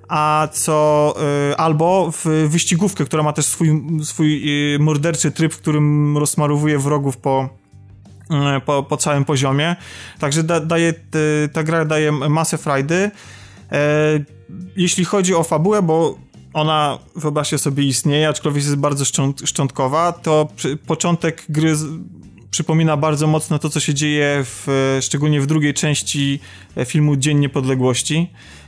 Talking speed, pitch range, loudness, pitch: 130 wpm, 140-160 Hz, -17 LUFS, 150 Hz